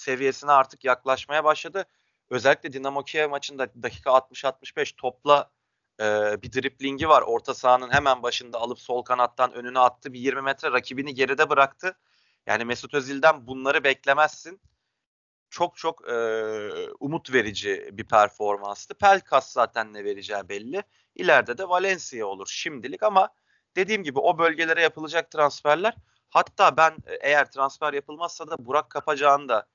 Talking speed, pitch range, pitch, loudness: 140 wpm, 130-160 Hz, 140 Hz, -24 LUFS